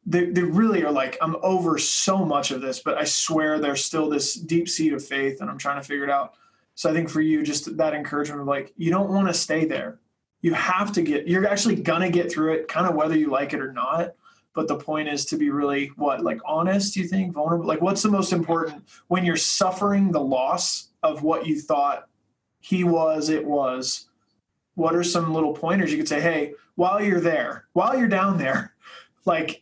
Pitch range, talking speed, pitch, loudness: 145-180 Hz, 225 wpm, 160 Hz, -23 LUFS